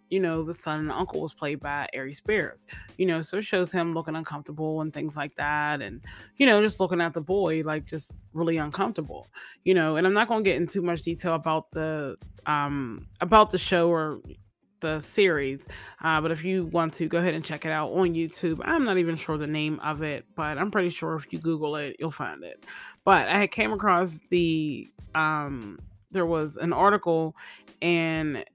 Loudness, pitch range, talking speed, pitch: -26 LUFS, 150-175 Hz, 210 wpm, 160 Hz